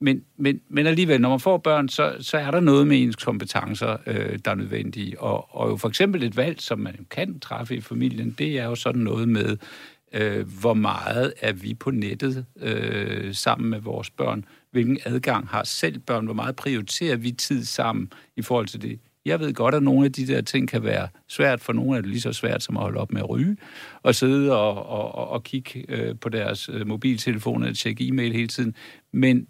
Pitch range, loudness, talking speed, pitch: 110-135 Hz, -24 LUFS, 220 wpm, 120 Hz